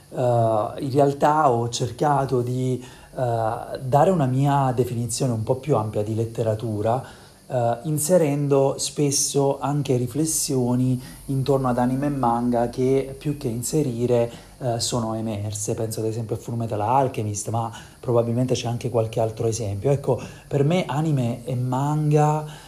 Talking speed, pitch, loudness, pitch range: 140 wpm, 125 Hz, -23 LUFS, 115-140 Hz